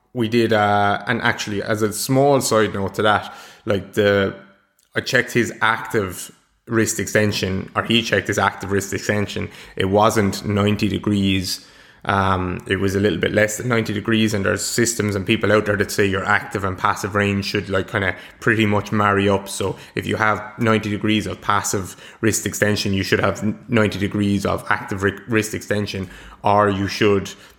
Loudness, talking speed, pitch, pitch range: -20 LUFS, 185 wpm, 105 Hz, 100-110 Hz